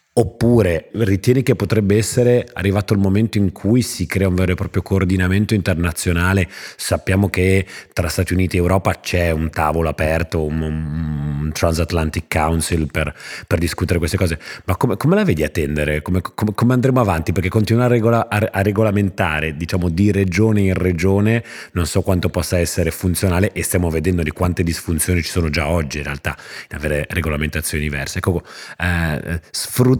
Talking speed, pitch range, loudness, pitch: 170 wpm, 80-100 Hz, -18 LUFS, 90 Hz